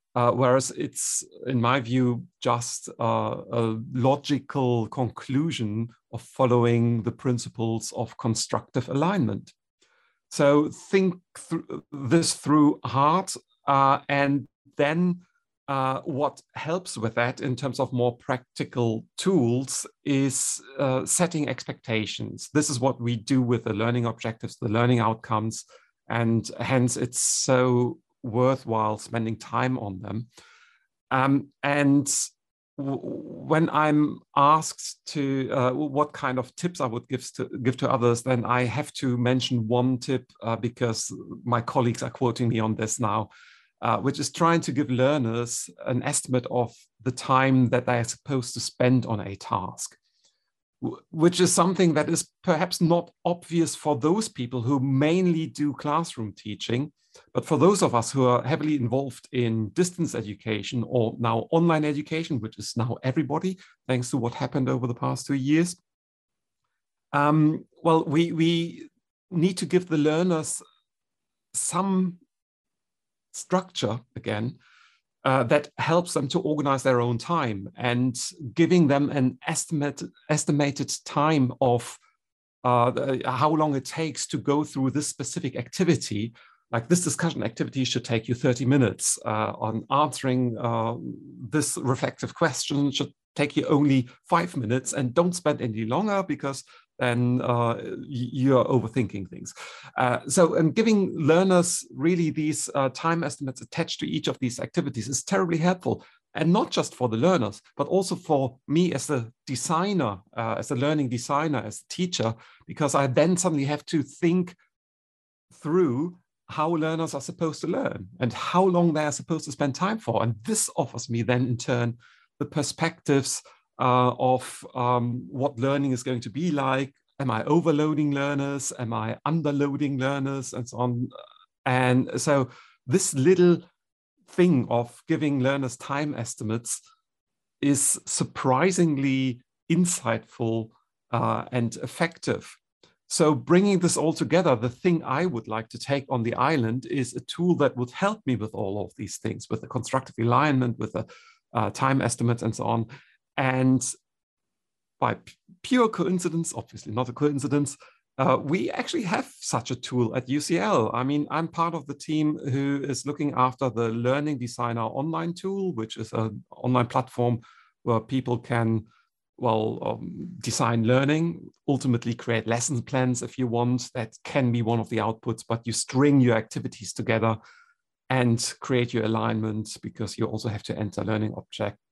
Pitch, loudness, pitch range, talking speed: 135 Hz, -25 LUFS, 120-155 Hz, 155 wpm